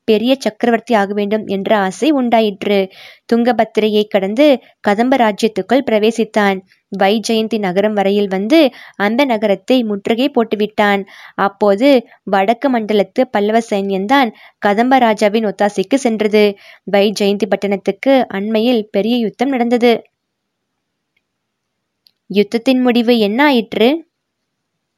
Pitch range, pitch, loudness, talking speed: 205-240 Hz, 220 Hz, -14 LUFS, 90 wpm